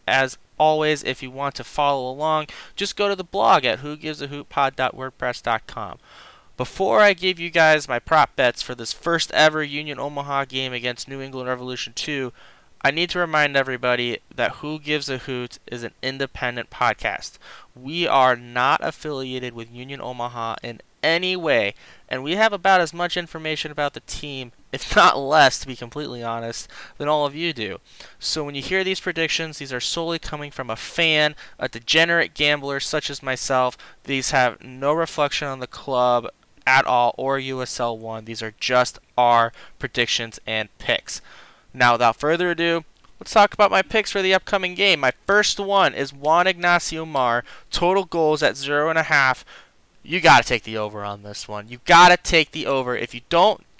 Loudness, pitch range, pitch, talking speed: -21 LUFS, 125-160 Hz, 140 Hz, 185 wpm